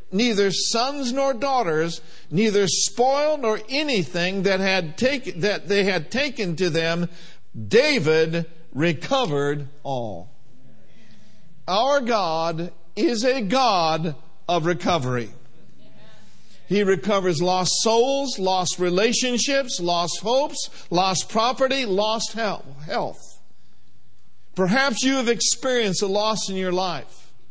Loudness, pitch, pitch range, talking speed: -22 LUFS, 195 Hz, 170-240 Hz, 105 wpm